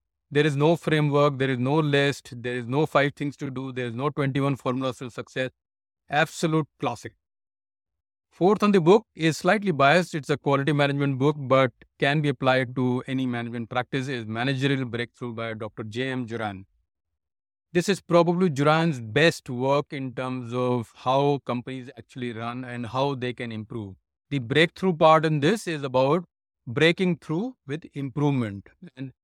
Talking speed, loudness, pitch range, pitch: 170 wpm, -24 LUFS, 120-155 Hz, 135 Hz